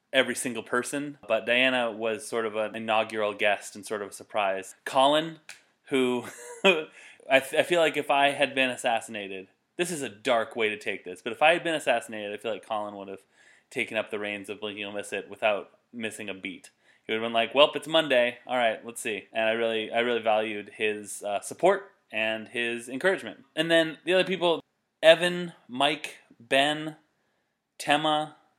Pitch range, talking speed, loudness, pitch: 110-155 Hz, 195 wpm, -27 LUFS, 120 Hz